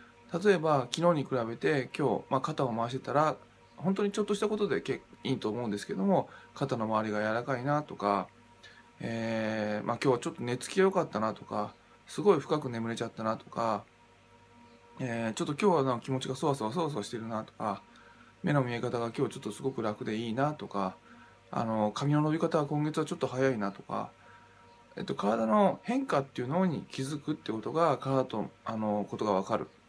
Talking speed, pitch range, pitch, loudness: 390 characters per minute, 110-150 Hz, 130 Hz, -32 LUFS